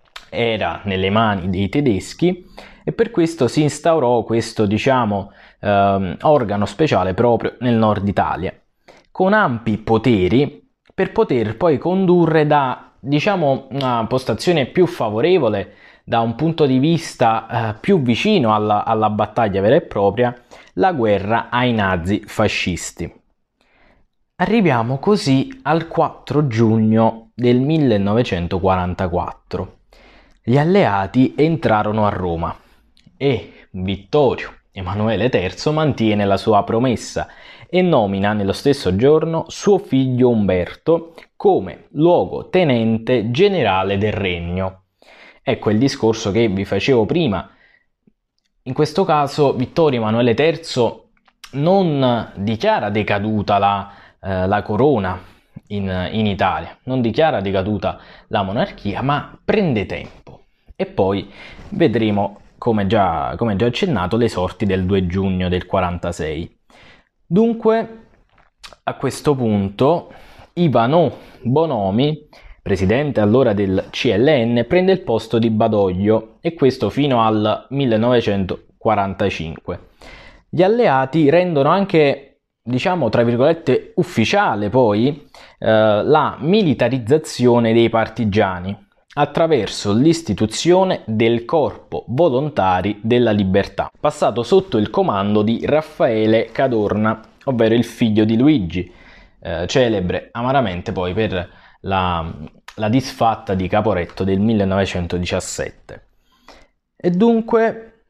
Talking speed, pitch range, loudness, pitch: 110 wpm, 100-145 Hz, -17 LUFS, 115 Hz